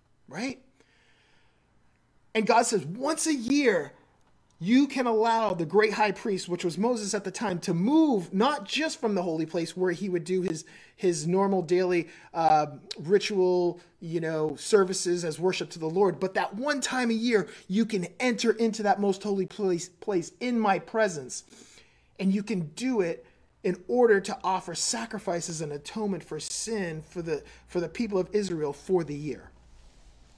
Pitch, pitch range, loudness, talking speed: 190 Hz, 170-220 Hz, -27 LUFS, 175 wpm